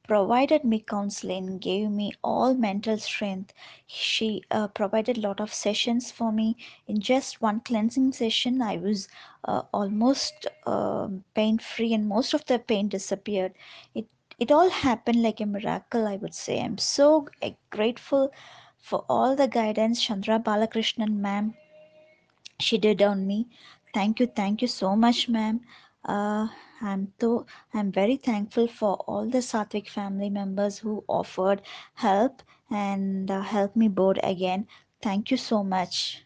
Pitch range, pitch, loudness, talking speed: 205-240 Hz, 215 Hz, -26 LUFS, 150 wpm